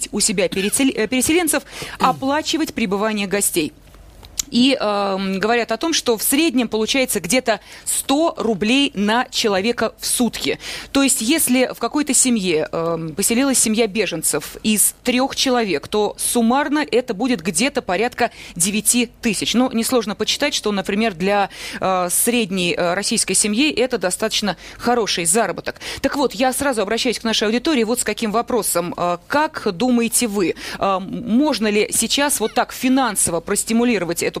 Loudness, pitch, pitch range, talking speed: -18 LUFS, 230 Hz, 205-255 Hz, 145 wpm